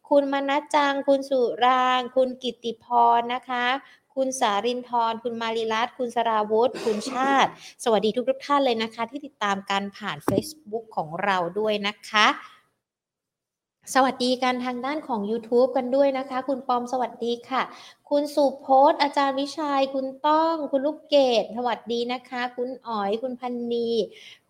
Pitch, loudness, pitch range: 250 Hz, -24 LUFS, 230-275 Hz